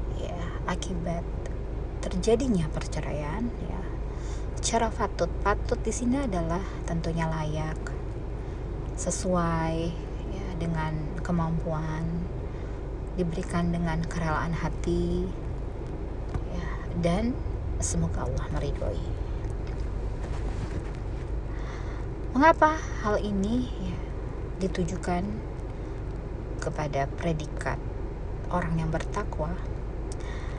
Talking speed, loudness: 70 wpm, -30 LUFS